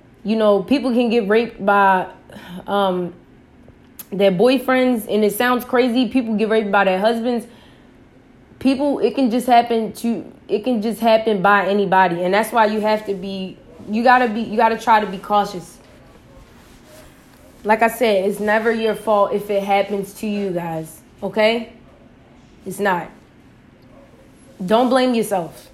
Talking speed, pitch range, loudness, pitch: 155 wpm, 200-235 Hz, -18 LUFS, 215 Hz